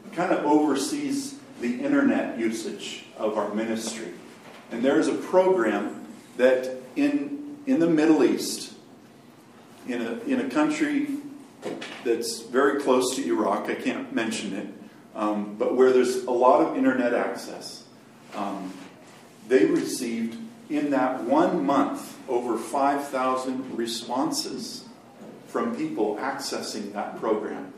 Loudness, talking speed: -25 LUFS, 125 wpm